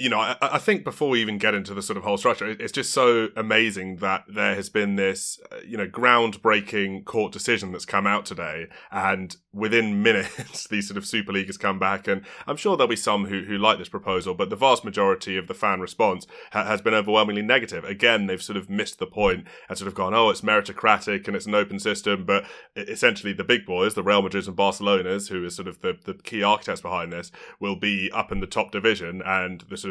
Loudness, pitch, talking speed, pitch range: -23 LUFS, 100 Hz, 235 wpm, 95-105 Hz